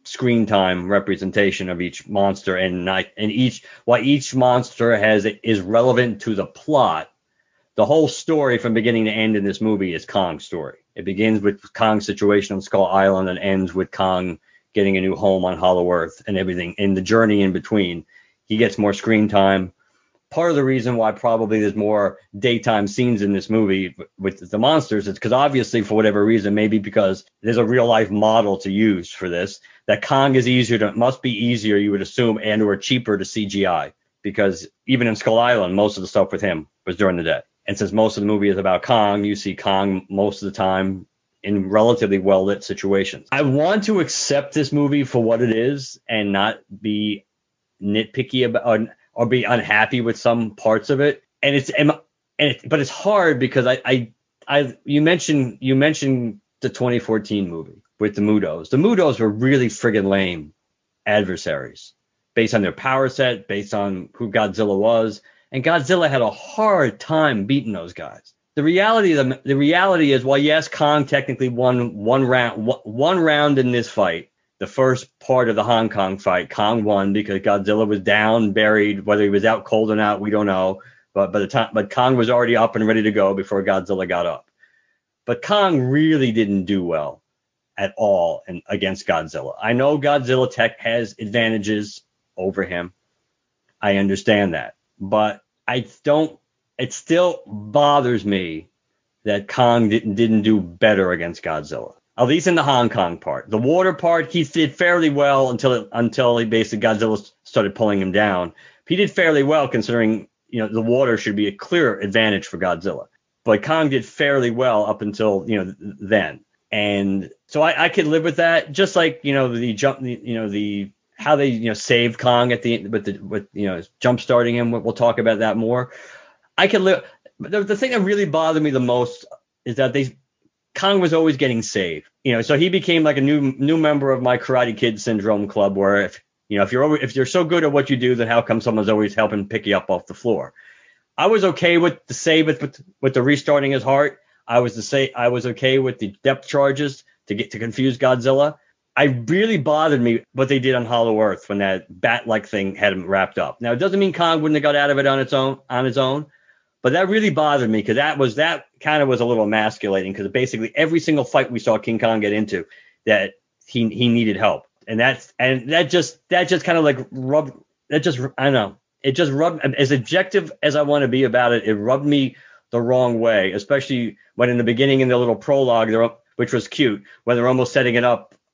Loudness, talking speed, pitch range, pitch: -19 LUFS, 210 wpm, 105-135 Hz, 115 Hz